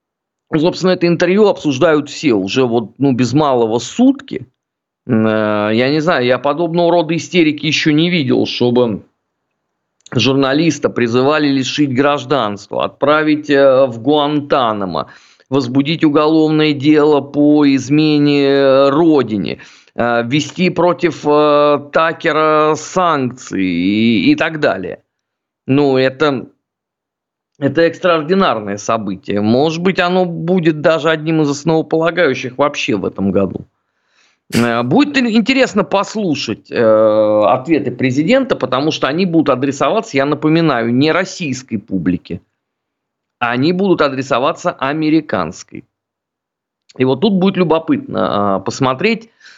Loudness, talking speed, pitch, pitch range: -14 LUFS, 105 wpm, 145 Hz, 125-165 Hz